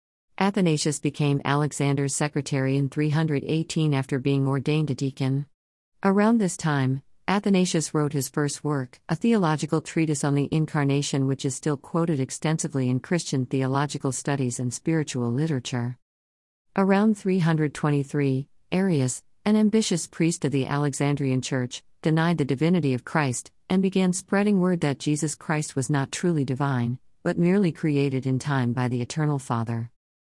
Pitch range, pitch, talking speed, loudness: 135-160 Hz, 145 Hz, 145 wpm, -25 LUFS